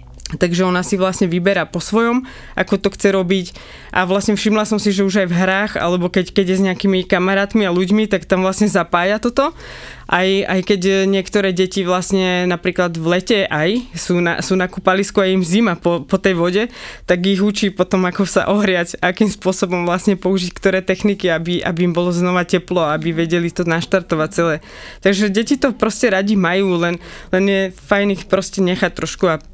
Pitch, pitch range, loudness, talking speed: 190 Hz, 180-200 Hz, -16 LUFS, 195 wpm